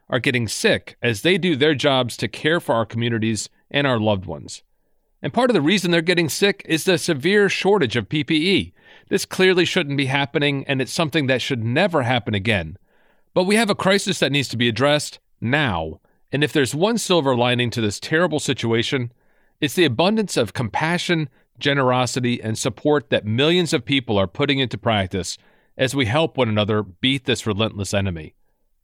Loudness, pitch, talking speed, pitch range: -20 LUFS, 140 Hz, 185 wpm, 115-165 Hz